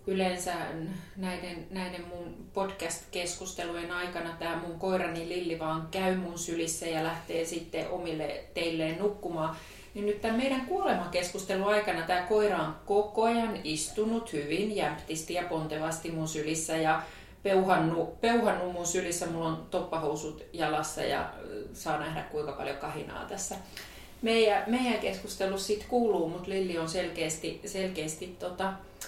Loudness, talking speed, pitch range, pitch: -32 LUFS, 135 wpm, 165-195 Hz, 180 Hz